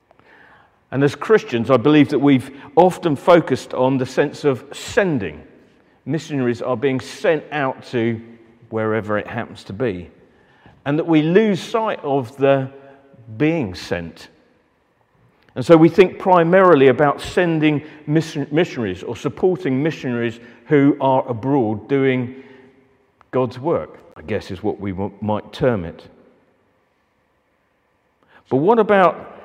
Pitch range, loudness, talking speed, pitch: 120-155 Hz, -18 LUFS, 125 wpm, 135 Hz